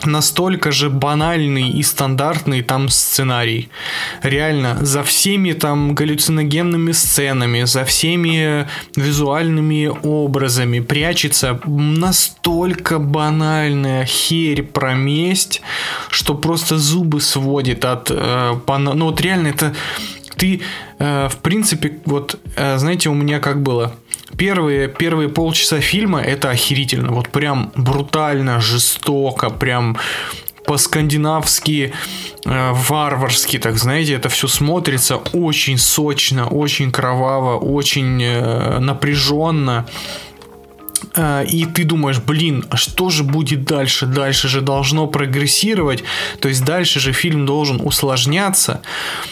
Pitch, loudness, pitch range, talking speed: 145 Hz, -15 LUFS, 135-155 Hz, 105 wpm